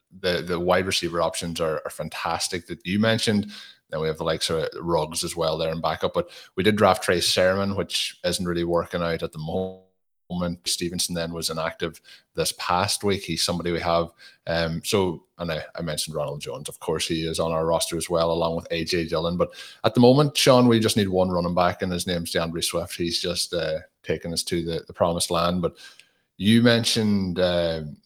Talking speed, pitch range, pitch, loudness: 210 wpm, 85-95 Hz, 85 Hz, -24 LUFS